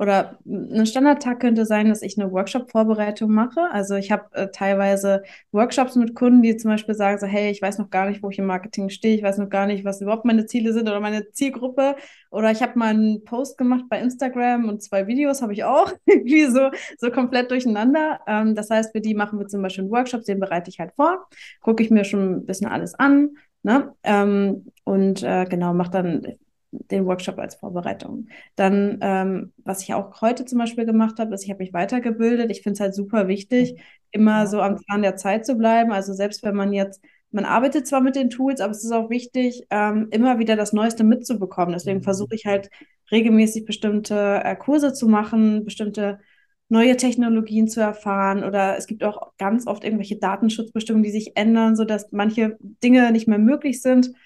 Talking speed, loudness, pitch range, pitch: 205 wpm, -21 LUFS, 200-245 Hz, 215 Hz